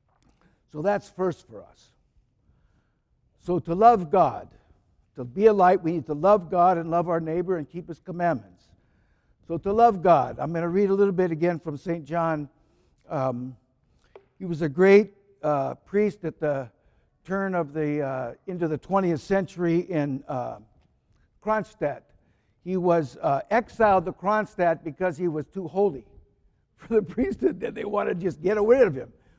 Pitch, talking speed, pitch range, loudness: 170 Hz, 170 wpm, 150-195 Hz, -24 LUFS